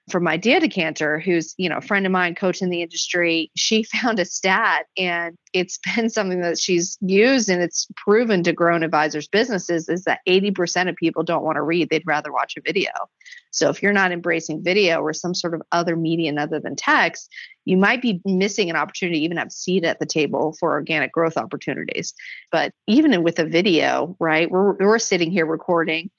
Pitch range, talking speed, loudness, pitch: 165-195 Hz, 210 wpm, -20 LUFS, 175 Hz